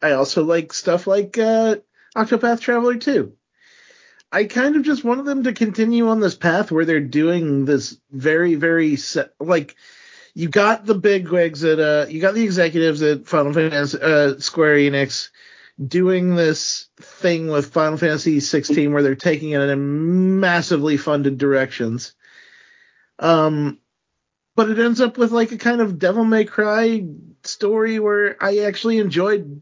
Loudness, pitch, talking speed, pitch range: -18 LUFS, 175 Hz, 160 wpm, 150-220 Hz